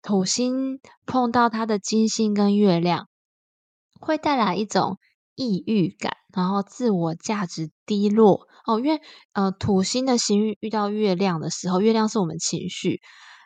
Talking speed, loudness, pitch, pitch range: 225 characters per minute, -23 LUFS, 210 Hz, 190-225 Hz